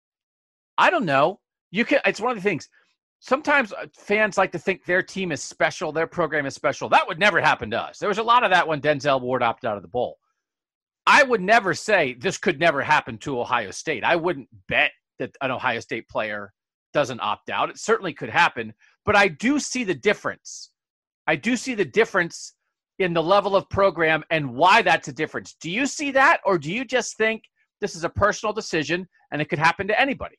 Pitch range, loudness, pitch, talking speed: 155-220 Hz, -22 LUFS, 185 Hz, 215 wpm